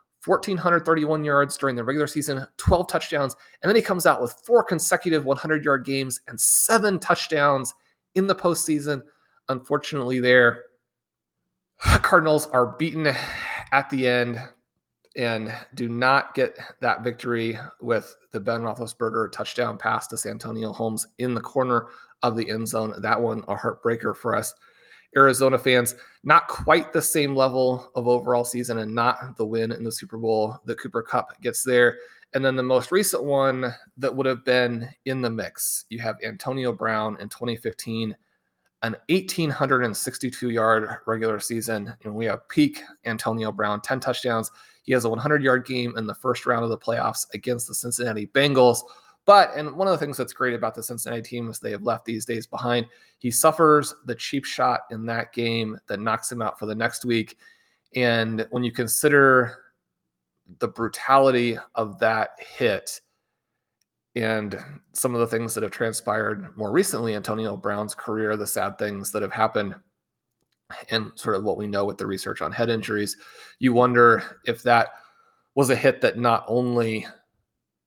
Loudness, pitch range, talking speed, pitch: -23 LUFS, 115-135 Hz, 170 wpm, 120 Hz